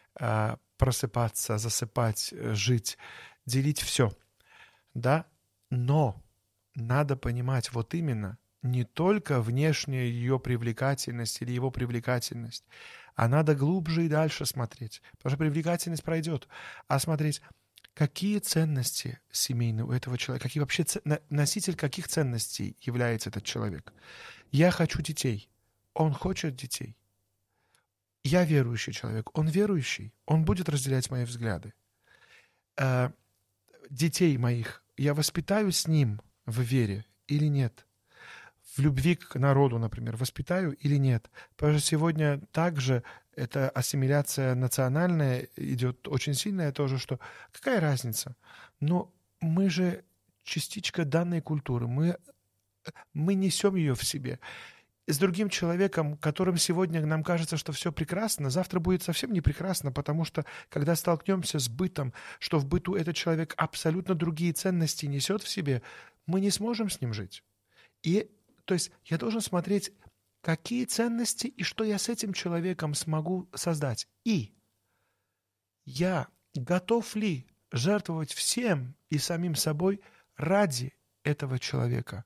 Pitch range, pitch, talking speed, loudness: 120-170 Hz, 145 Hz, 125 wpm, -29 LUFS